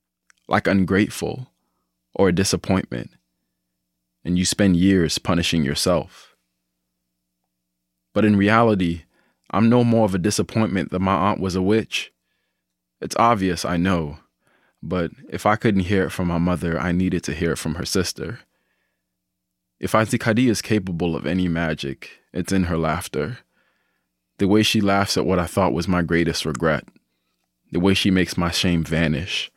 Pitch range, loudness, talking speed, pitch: 60-100 Hz, -21 LUFS, 155 wpm, 90 Hz